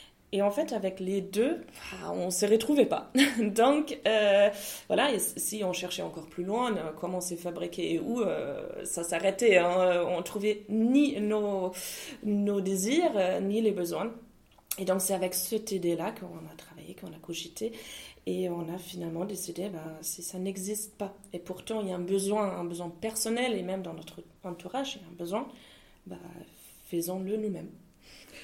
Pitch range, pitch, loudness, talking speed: 180-220 Hz, 195 Hz, -30 LUFS, 175 wpm